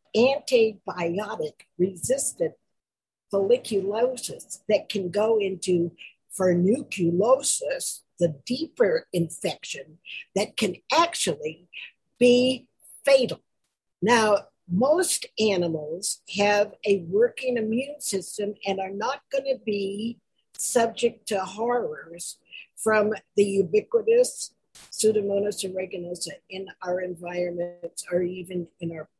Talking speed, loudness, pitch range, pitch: 90 wpm, -25 LUFS, 180-245 Hz, 205 Hz